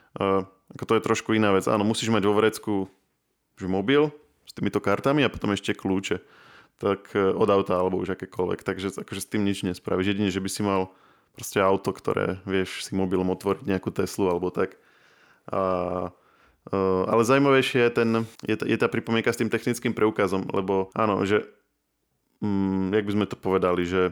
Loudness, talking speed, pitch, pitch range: -25 LUFS, 180 wpm, 100 Hz, 95-110 Hz